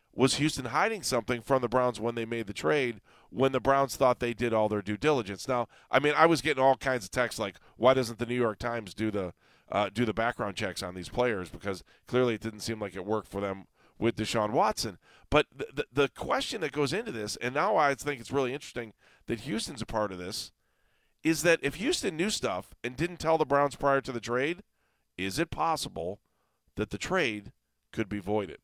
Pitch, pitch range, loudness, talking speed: 120 Hz, 105-135 Hz, -30 LUFS, 225 wpm